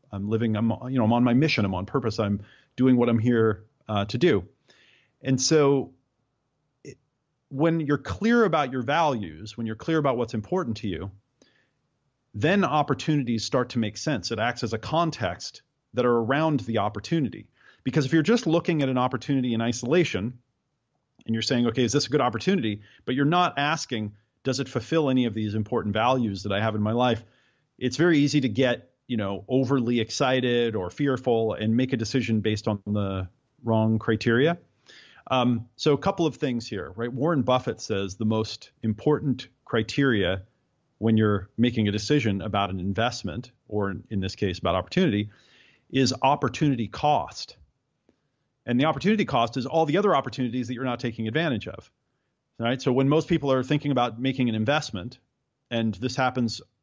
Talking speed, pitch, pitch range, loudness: 180 wpm, 125 Hz, 110-140 Hz, -25 LUFS